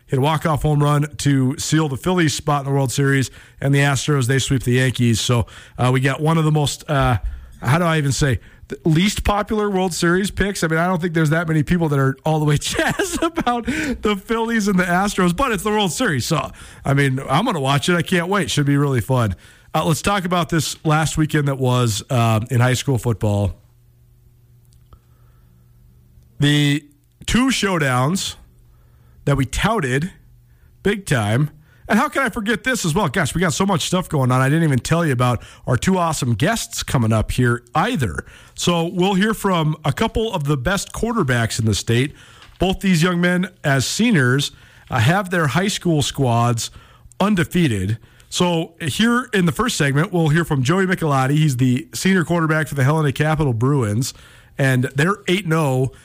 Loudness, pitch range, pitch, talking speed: -19 LUFS, 125-180 Hz, 150 Hz, 195 wpm